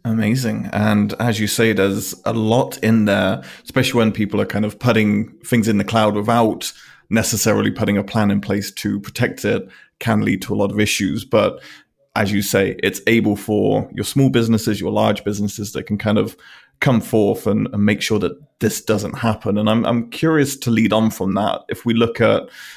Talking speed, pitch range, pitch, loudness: 205 wpm, 105-115 Hz, 110 Hz, -18 LUFS